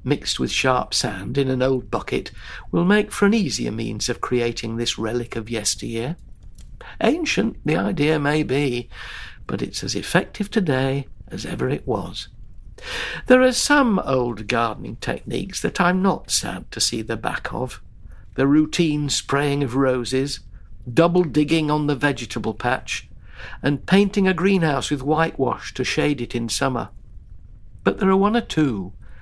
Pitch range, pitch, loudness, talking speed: 120-170 Hz, 140 Hz, -21 LUFS, 160 wpm